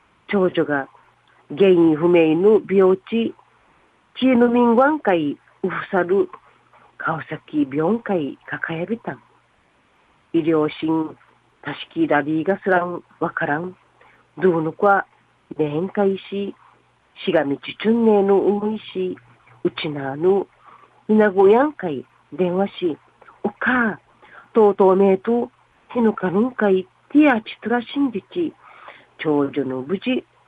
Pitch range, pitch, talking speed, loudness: 165-225 Hz, 195 Hz, 190 characters per minute, -20 LUFS